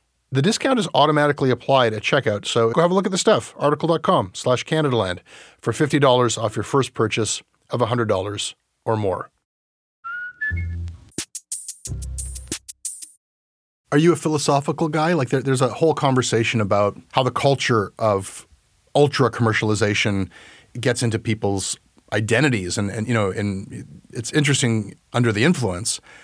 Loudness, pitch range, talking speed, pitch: -21 LUFS, 105-150 Hz, 135 wpm, 120 Hz